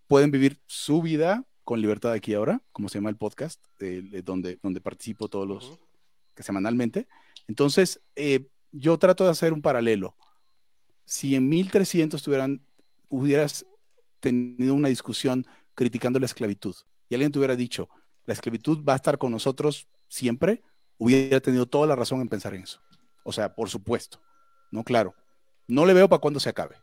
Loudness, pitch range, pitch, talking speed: -25 LUFS, 115-150 Hz, 135 Hz, 170 wpm